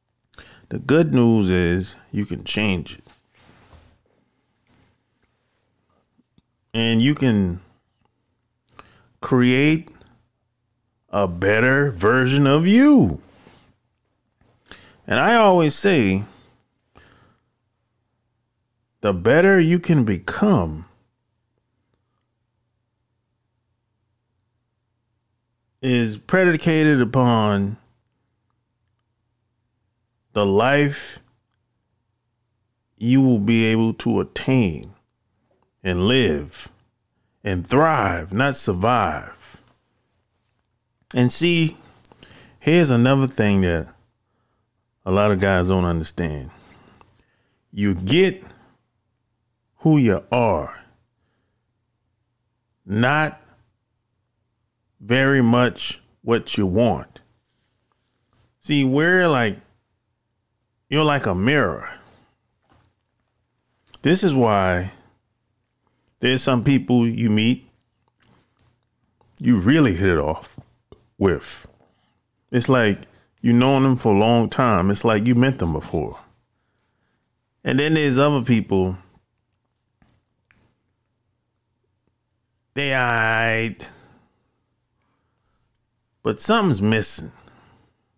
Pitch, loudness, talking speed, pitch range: 115 Hz, -19 LUFS, 75 wpm, 110-125 Hz